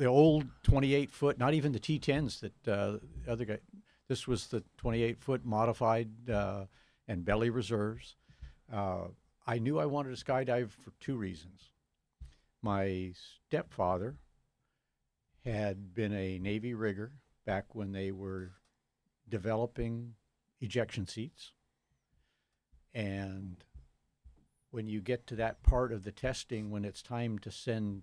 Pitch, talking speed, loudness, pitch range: 110 Hz, 135 wpm, -35 LUFS, 95-125 Hz